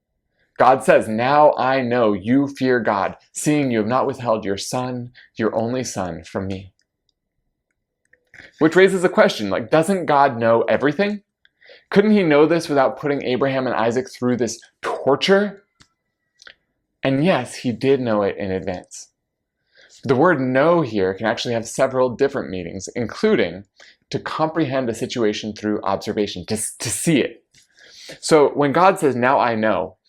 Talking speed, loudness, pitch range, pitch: 155 wpm, -19 LUFS, 110-145 Hz, 125 Hz